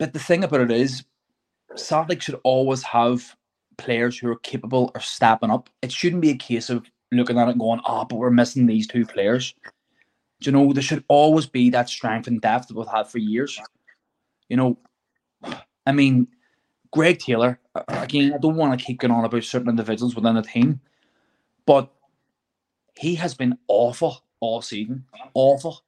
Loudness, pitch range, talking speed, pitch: -21 LUFS, 120-140 Hz, 185 wpm, 125 Hz